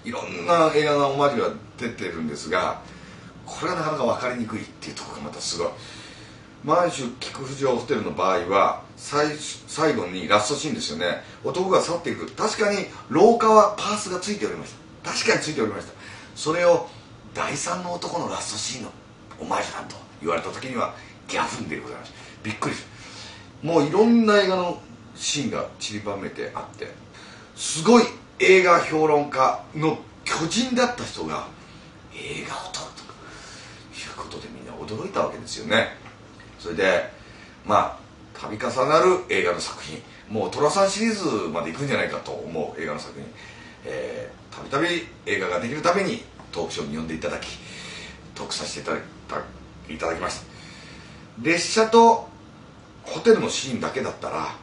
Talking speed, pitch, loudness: 345 characters per minute, 160 Hz, -23 LUFS